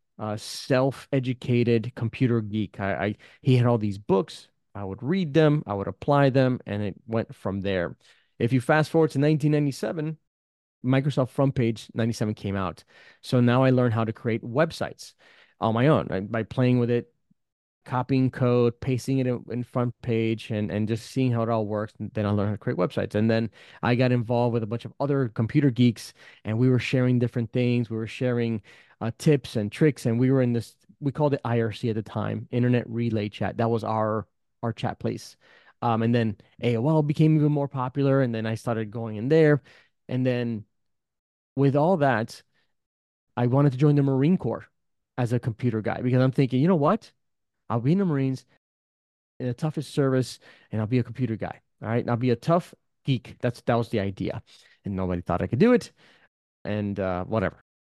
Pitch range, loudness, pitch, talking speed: 110-135 Hz, -25 LUFS, 120 Hz, 205 wpm